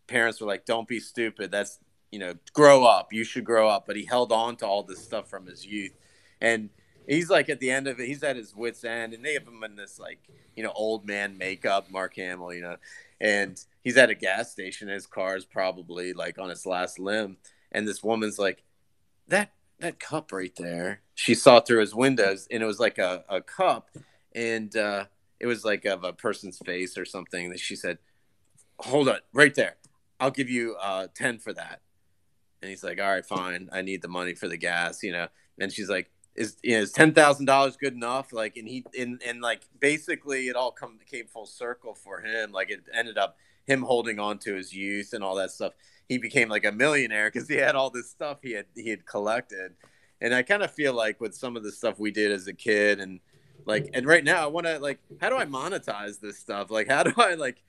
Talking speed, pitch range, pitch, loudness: 235 wpm, 95-120 Hz, 105 Hz, -26 LUFS